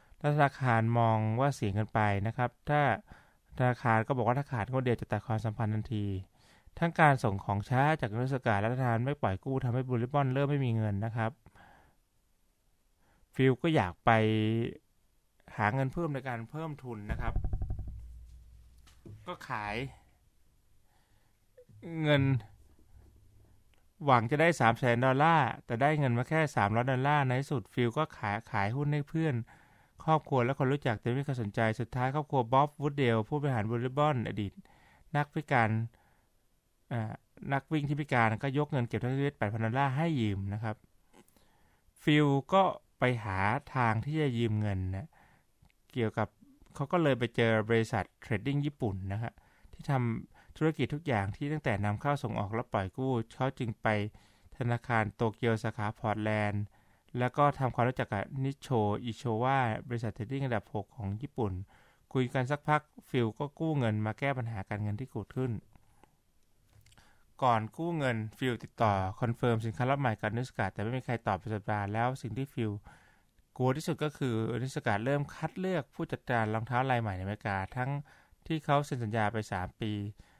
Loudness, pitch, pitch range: -32 LUFS, 120 Hz, 105-135 Hz